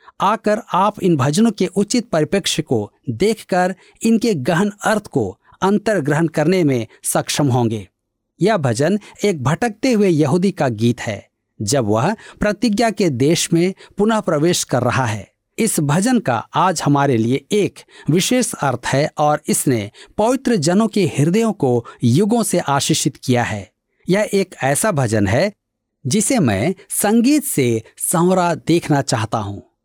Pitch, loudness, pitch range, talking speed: 170 Hz, -17 LUFS, 130-210 Hz, 150 wpm